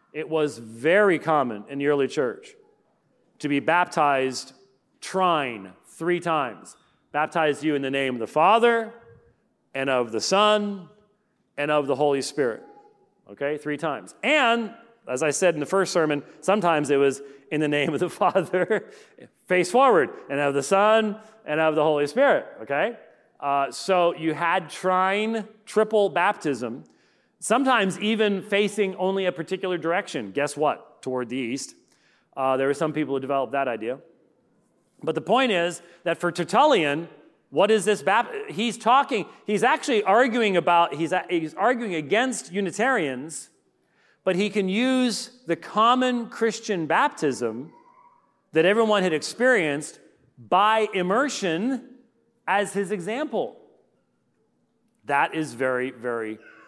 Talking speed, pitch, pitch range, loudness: 140 wpm, 175 Hz, 145-215 Hz, -23 LUFS